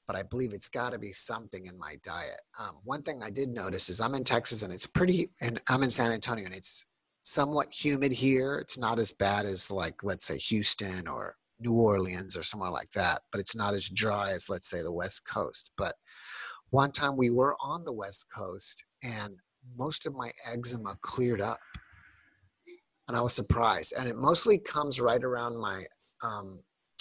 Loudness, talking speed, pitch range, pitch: -29 LUFS, 200 wpm, 100-130 Hz, 115 Hz